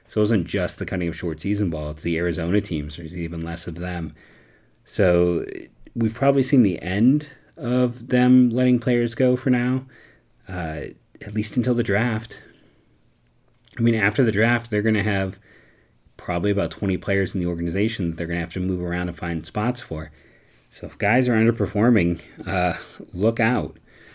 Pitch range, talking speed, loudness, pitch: 85-120 Hz, 185 wpm, -22 LUFS, 105 Hz